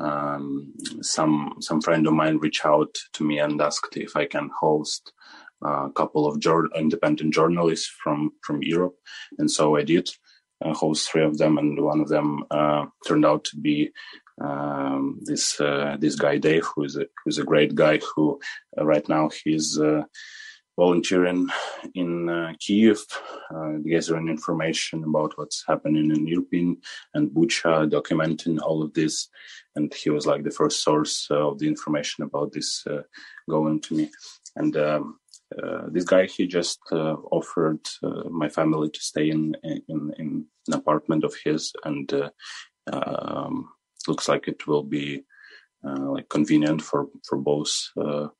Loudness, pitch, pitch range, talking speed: -24 LUFS, 75 Hz, 75-80 Hz, 165 wpm